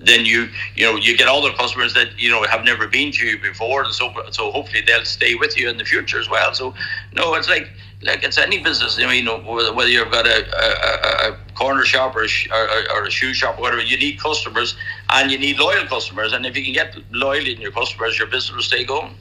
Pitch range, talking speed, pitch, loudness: 105-130 Hz, 245 wpm, 115 Hz, -16 LUFS